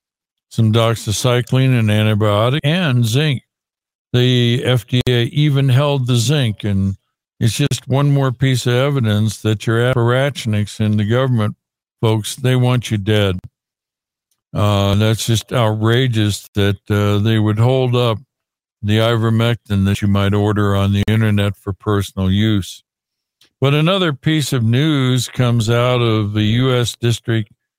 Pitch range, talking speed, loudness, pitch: 105-125 Hz, 140 wpm, -16 LUFS, 115 Hz